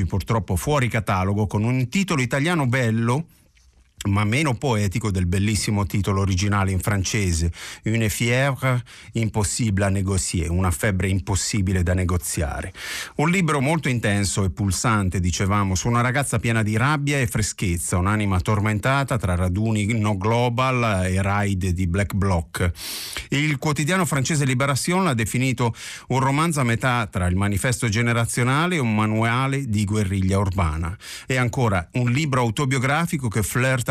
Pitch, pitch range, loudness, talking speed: 110 Hz, 100-130 Hz, -22 LUFS, 140 wpm